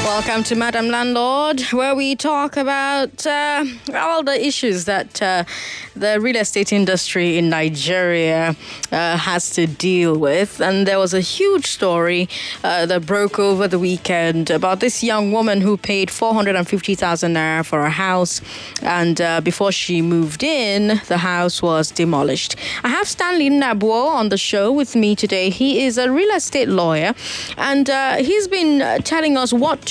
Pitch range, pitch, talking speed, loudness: 175-260 Hz, 200 Hz, 165 wpm, -17 LUFS